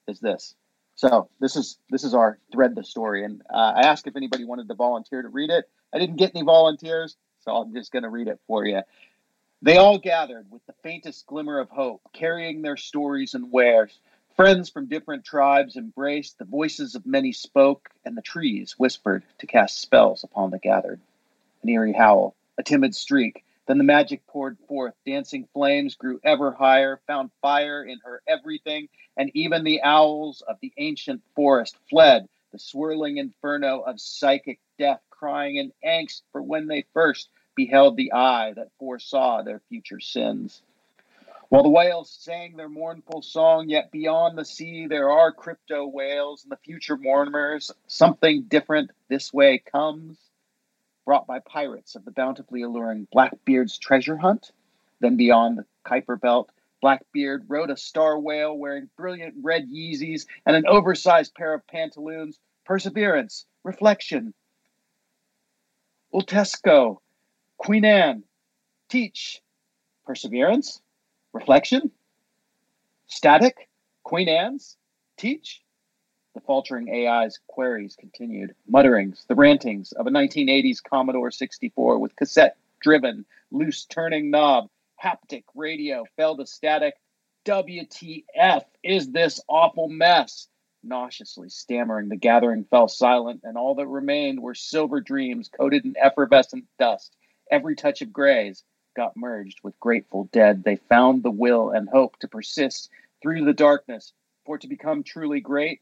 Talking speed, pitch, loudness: 150 wpm, 155 Hz, -21 LUFS